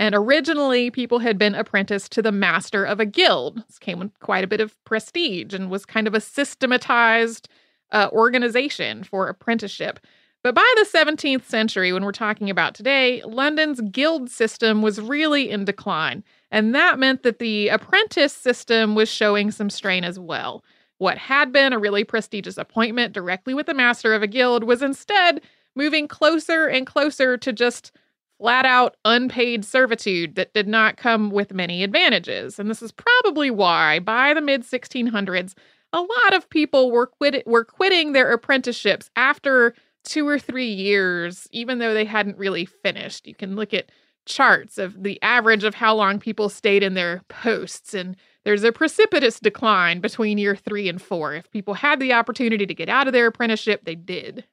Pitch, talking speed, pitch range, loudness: 225 Hz, 175 wpm, 205-260 Hz, -19 LUFS